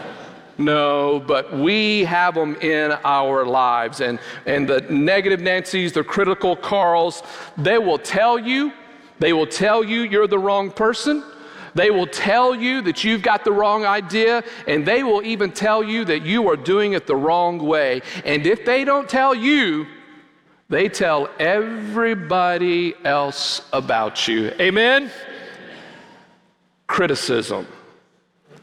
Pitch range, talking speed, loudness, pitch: 160-230 Hz, 140 wpm, -19 LUFS, 200 Hz